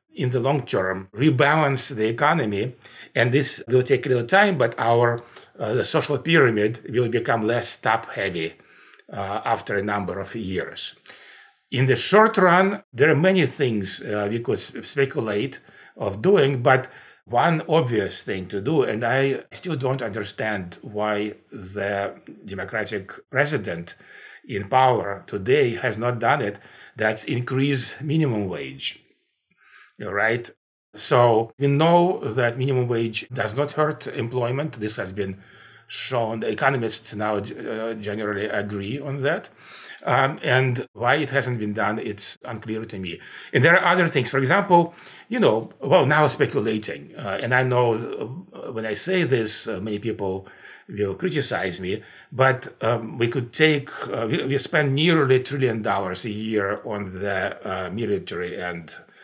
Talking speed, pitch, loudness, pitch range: 150 wpm, 120 Hz, -22 LUFS, 105-140 Hz